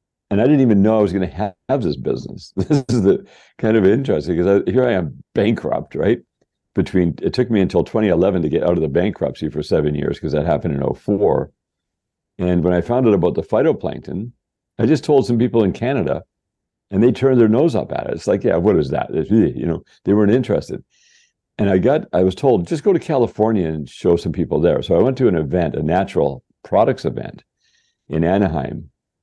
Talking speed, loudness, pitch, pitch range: 225 wpm, -18 LUFS, 105 Hz, 90-125 Hz